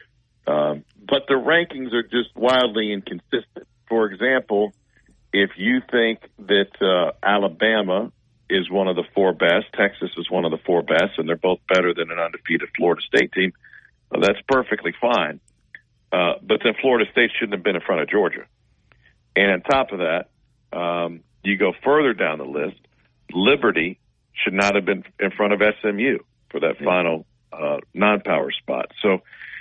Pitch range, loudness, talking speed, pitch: 90-120 Hz, -21 LUFS, 170 wpm, 105 Hz